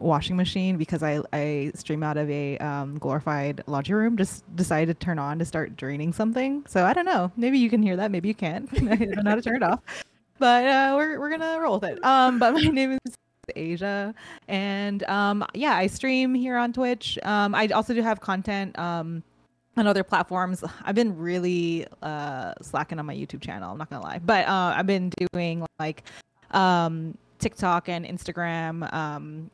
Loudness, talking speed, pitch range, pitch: -25 LUFS, 195 wpm, 160-225 Hz, 185 Hz